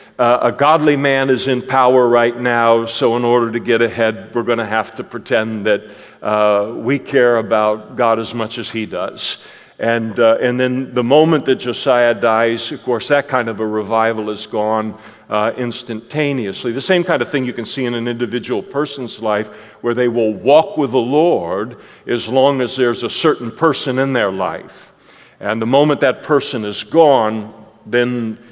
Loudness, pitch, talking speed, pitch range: -16 LUFS, 120 Hz, 195 wpm, 110-130 Hz